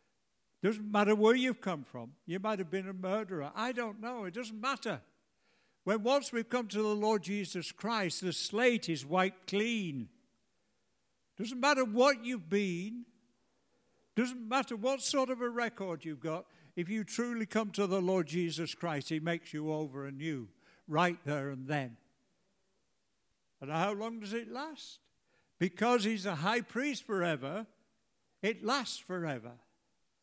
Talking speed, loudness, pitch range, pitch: 155 wpm, -34 LUFS, 170-235 Hz, 205 Hz